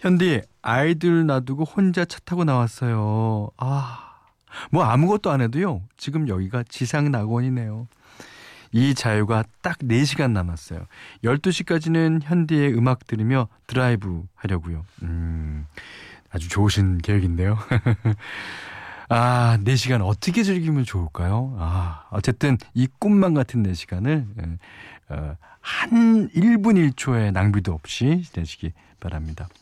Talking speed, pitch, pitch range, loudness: 250 characters per minute, 120 Hz, 100-150 Hz, -22 LUFS